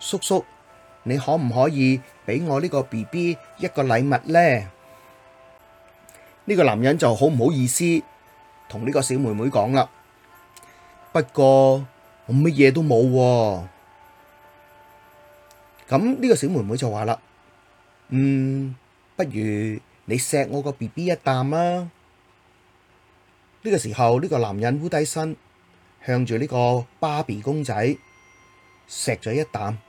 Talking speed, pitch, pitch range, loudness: 185 characters per minute, 125 Hz, 100-145 Hz, -21 LUFS